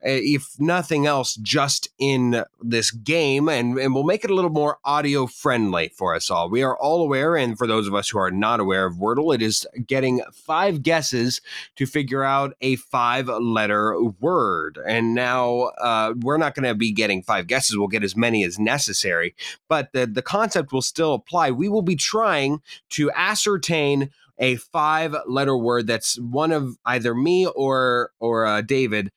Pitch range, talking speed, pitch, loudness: 115-150 Hz, 185 wpm, 130 Hz, -21 LUFS